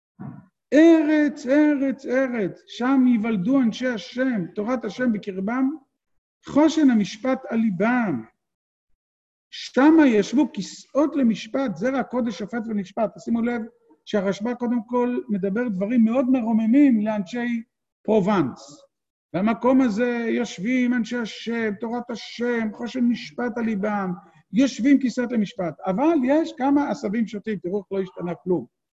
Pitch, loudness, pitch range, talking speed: 240 Hz, -22 LUFS, 210-260 Hz, 120 wpm